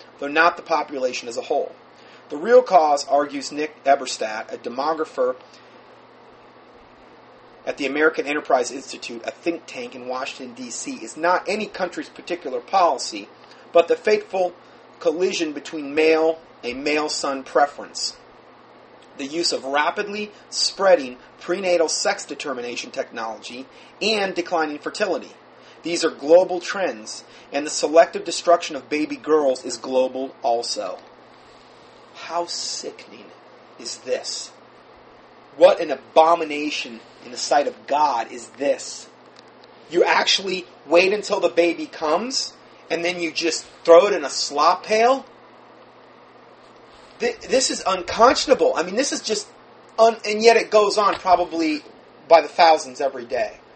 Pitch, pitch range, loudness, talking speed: 170 Hz, 150-210 Hz, -21 LUFS, 135 wpm